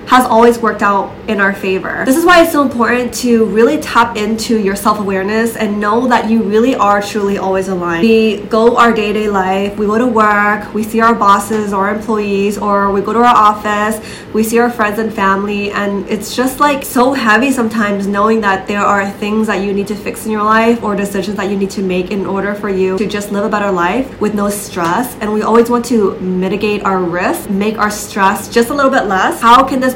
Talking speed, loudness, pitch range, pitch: 235 wpm, -12 LUFS, 200-230 Hz, 210 Hz